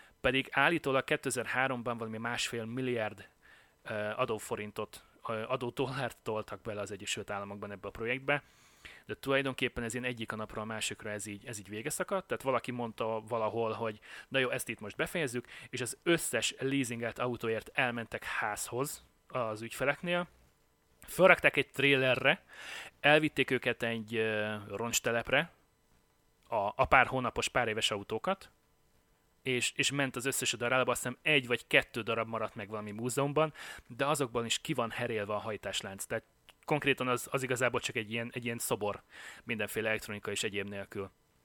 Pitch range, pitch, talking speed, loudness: 110-135 Hz, 120 Hz, 150 wpm, -33 LUFS